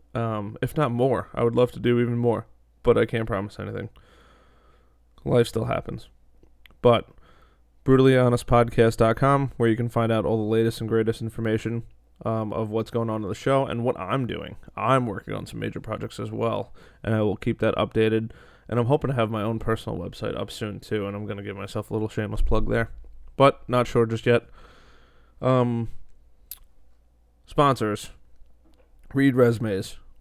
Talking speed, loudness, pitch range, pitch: 180 wpm, -24 LUFS, 105-120 Hz, 115 Hz